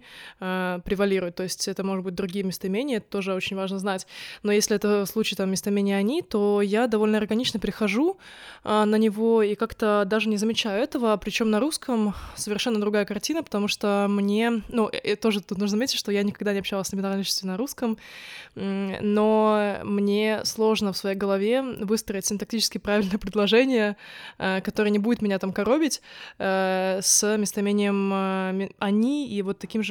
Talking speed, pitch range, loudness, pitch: 160 wpm, 200-220 Hz, -24 LUFS, 210 Hz